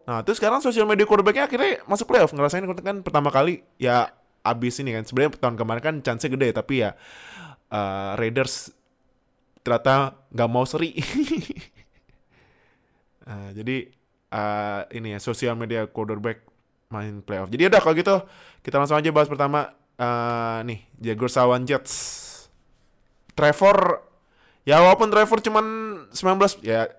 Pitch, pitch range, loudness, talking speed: 130 Hz, 115-180 Hz, -22 LUFS, 140 wpm